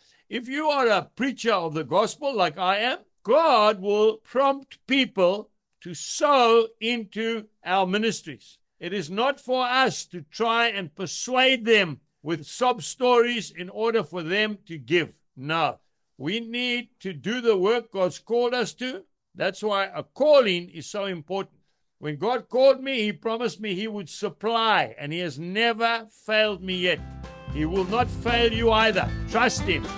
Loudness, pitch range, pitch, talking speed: -24 LUFS, 185-235 Hz, 215 Hz, 165 wpm